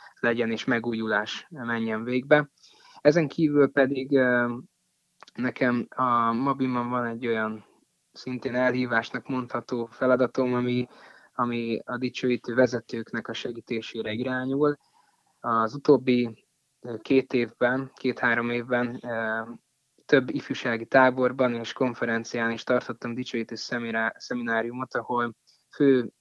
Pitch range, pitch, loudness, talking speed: 115-130 Hz, 125 Hz, -26 LUFS, 100 wpm